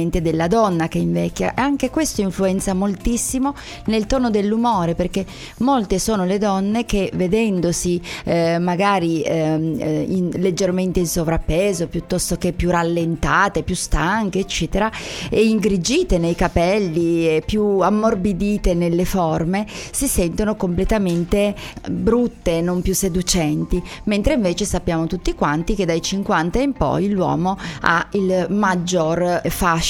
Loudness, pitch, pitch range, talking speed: -19 LUFS, 185 Hz, 170-205 Hz, 125 wpm